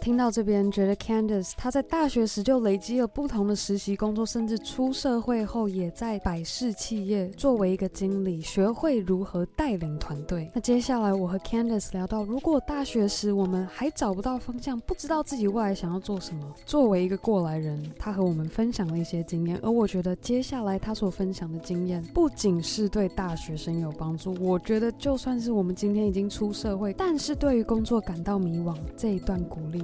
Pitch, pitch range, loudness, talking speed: 205 Hz, 185-235 Hz, -28 LUFS, 335 characters per minute